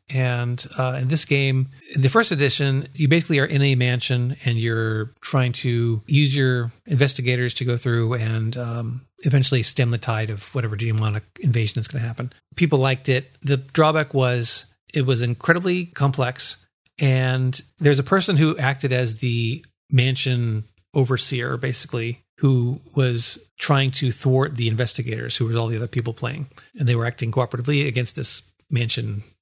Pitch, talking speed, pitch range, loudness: 125 Hz, 165 wpm, 120-140 Hz, -22 LUFS